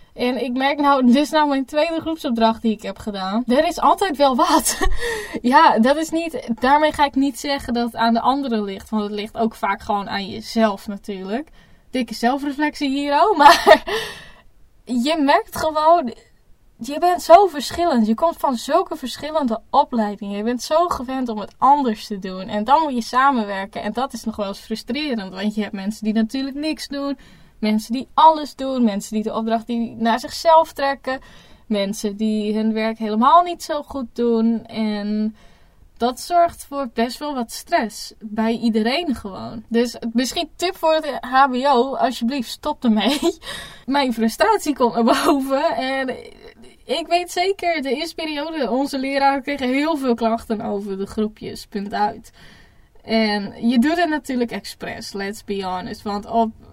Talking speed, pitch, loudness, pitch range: 175 wpm, 245 Hz, -20 LUFS, 220-290 Hz